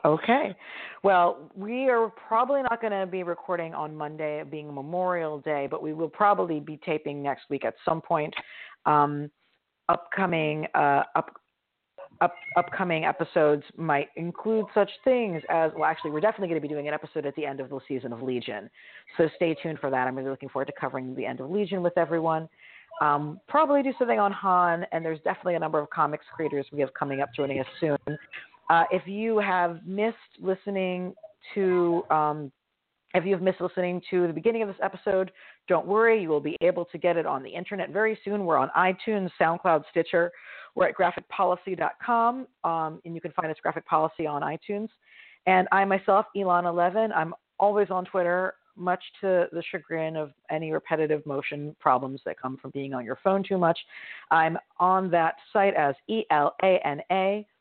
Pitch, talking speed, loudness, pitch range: 170 Hz, 190 wpm, -27 LUFS, 150-195 Hz